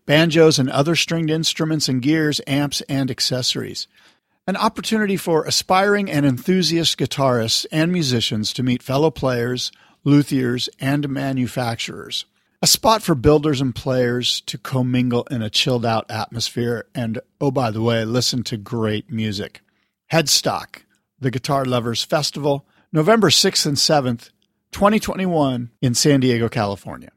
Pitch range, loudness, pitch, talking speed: 120-155 Hz, -19 LUFS, 135 Hz, 135 wpm